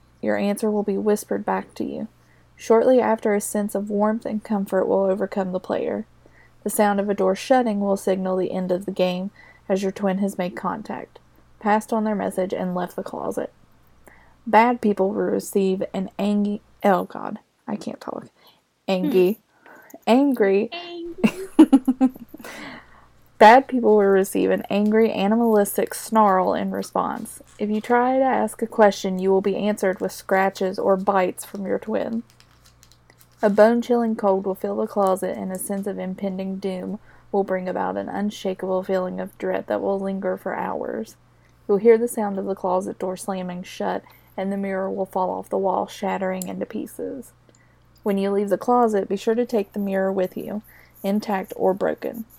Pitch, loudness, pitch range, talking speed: 200 Hz, -22 LUFS, 190-220 Hz, 175 wpm